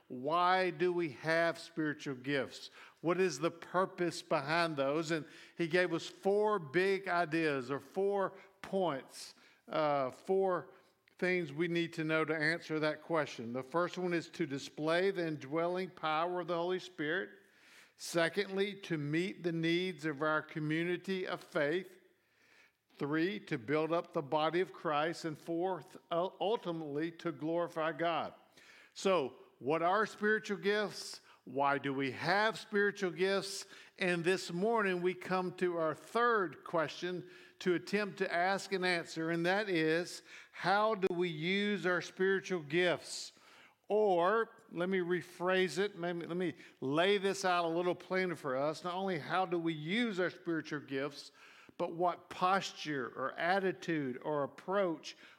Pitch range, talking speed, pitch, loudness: 160-190 Hz, 150 wpm, 175 Hz, -35 LUFS